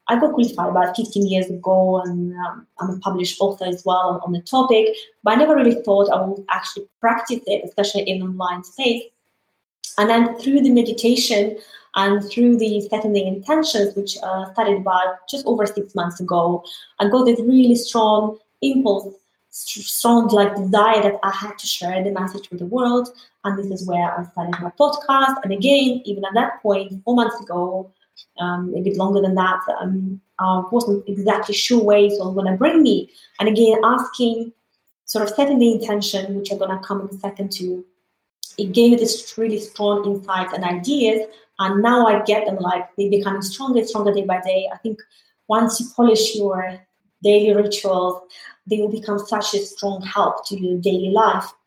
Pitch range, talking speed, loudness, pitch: 190-230 Hz, 190 wpm, -19 LUFS, 205 Hz